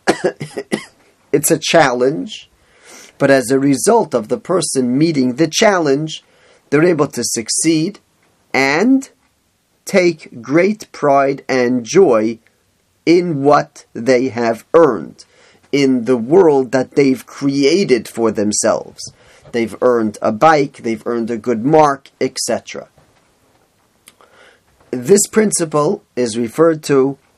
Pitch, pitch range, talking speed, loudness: 135 Hz, 120-160 Hz, 110 wpm, -15 LUFS